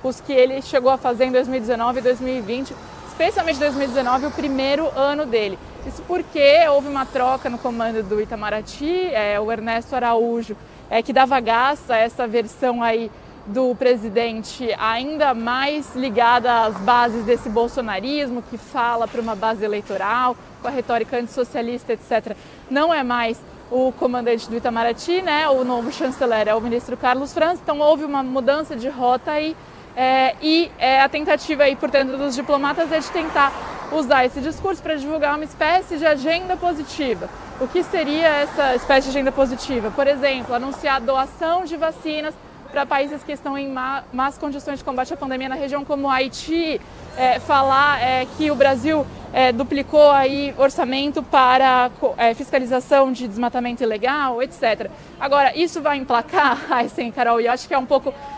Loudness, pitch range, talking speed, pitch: -20 LUFS, 245-290 Hz, 165 wpm, 265 Hz